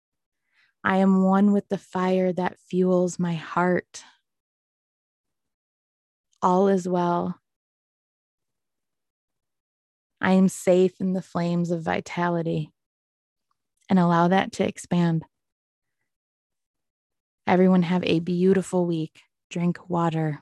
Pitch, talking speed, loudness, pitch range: 175 Hz, 95 wpm, -23 LUFS, 155-185 Hz